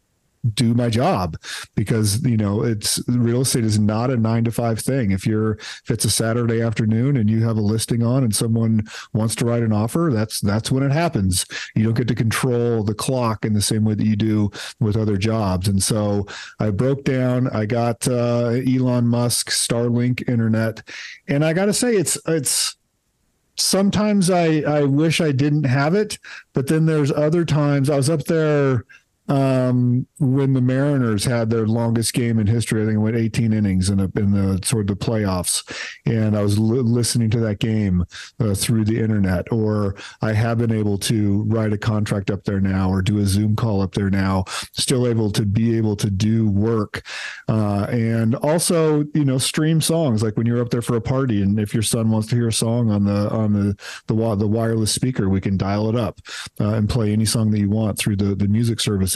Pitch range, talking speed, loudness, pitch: 105-125 Hz, 210 wpm, -20 LUFS, 115 Hz